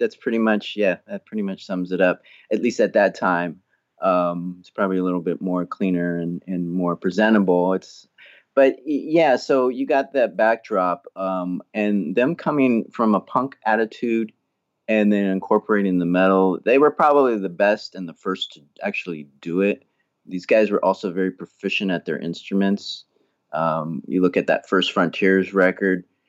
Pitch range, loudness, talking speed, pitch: 90-110 Hz, -21 LUFS, 175 wpm, 95 Hz